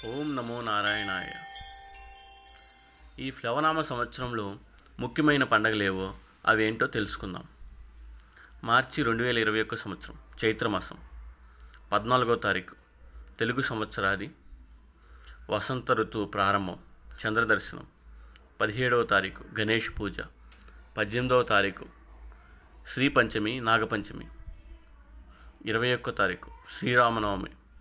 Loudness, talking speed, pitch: -28 LUFS, 85 wpm, 100 Hz